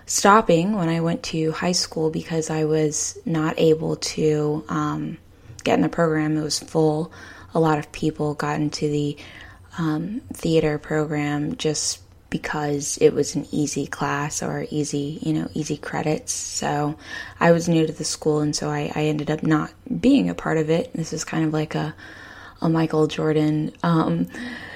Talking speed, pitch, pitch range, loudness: 175 wpm, 155 Hz, 150-160 Hz, -22 LUFS